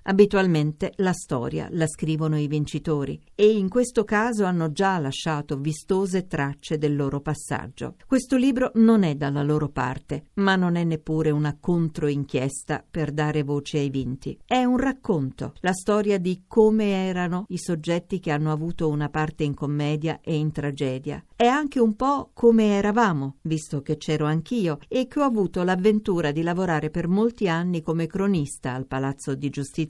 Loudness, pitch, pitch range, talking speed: -24 LUFS, 165 Hz, 150-195 Hz, 165 wpm